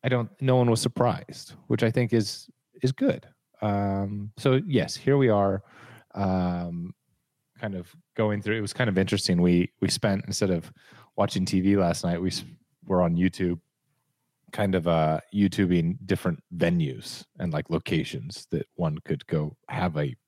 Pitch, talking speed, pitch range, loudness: 100 Hz, 170 wpm, 90-120 Hz, -26 LUFS